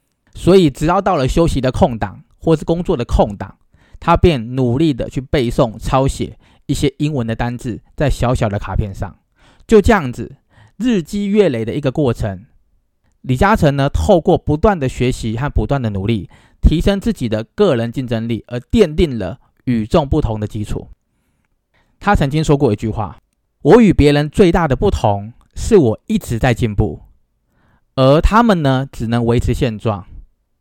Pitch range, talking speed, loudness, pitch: 110-160 Hz, 250 characters per minute, -16 LUFS, 130 Hz